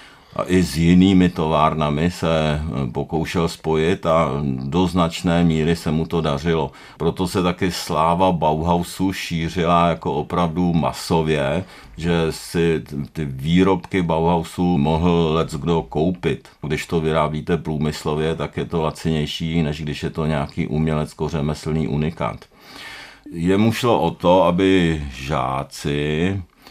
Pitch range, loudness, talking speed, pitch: 75-85 Hz, -20 LUFS, 125 wpm, 80 Hz